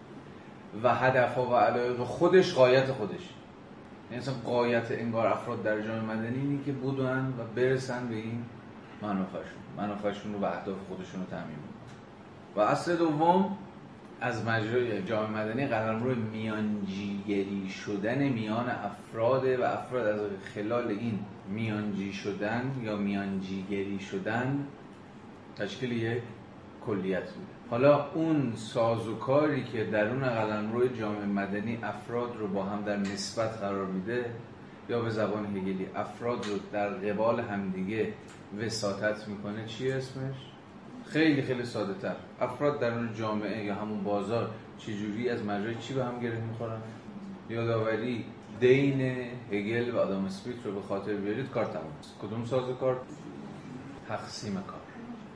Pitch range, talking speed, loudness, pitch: 105-125 Hz, 130 wpm, -31 LUFS, 115 Hz